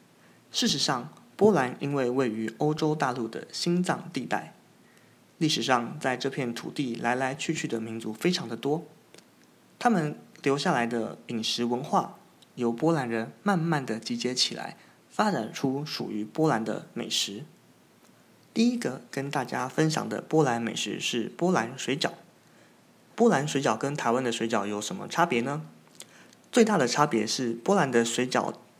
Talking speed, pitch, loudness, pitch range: 235 characters per minute, 130 Hz, -28 LUFS, 115-155 Hz